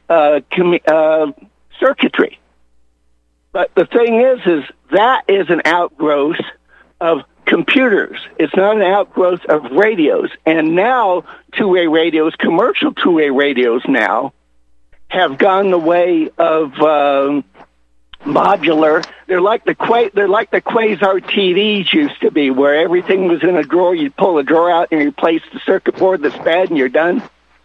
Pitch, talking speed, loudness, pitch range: 175 Hz, 155 wpm, -13 LUFS, 150-195 Hz